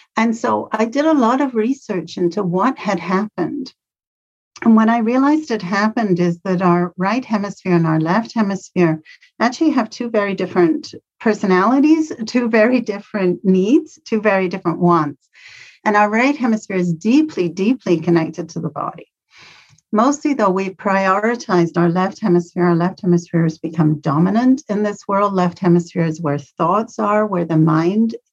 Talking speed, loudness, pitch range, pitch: 165 wpm, -17 LUFS, 175-230 Hz, 200 Hz